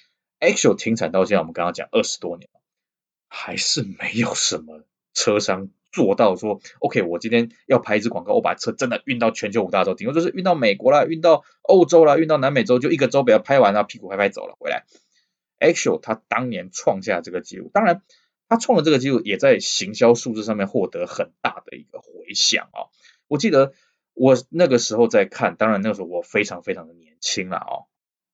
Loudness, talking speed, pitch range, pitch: -20 LUFS, 335 characters per minute, 115-185 Hz, 140 Hz